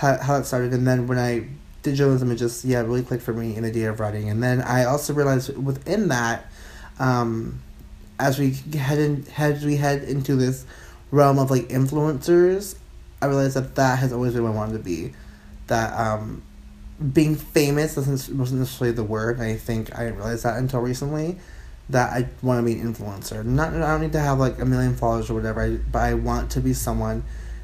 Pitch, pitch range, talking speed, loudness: 125 Hz, 115-140 Hz, 210 wpm, -23 LUFS